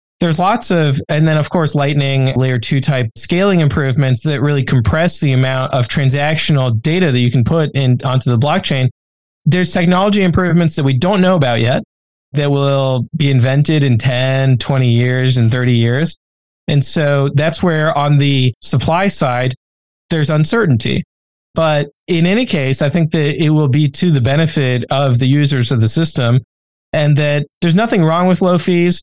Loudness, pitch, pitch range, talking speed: -13 LUFS, 145 Hz, 130-165 Hz, 180 wpm